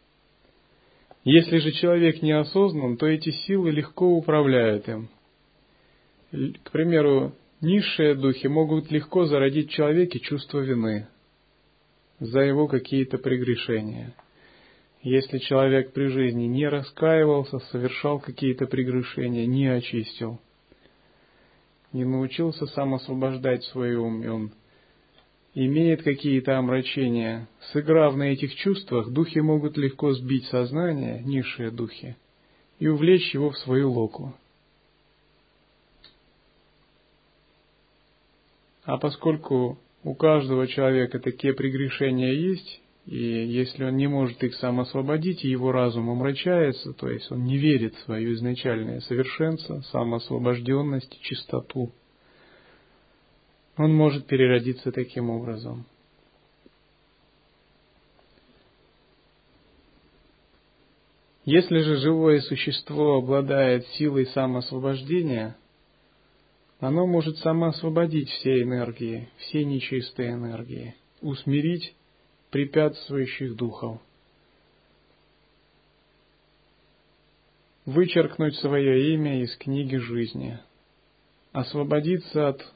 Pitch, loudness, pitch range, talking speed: 135 Hz, -24 LUFS, 125-150 Hz, 90 wpm